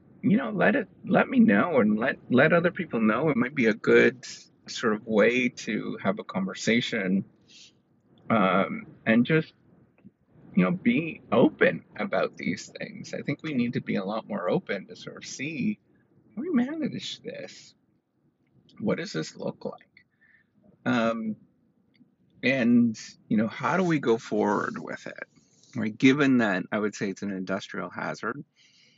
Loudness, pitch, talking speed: -26 LUFS, 140 Hz, 165 wpm